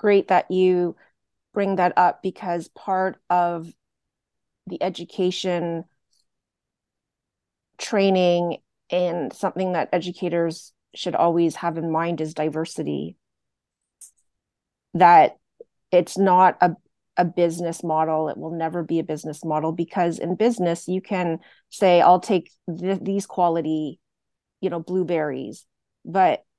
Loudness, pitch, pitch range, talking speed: -22 LUFS, 175 Hz, 165-185 Hz, 115 wpm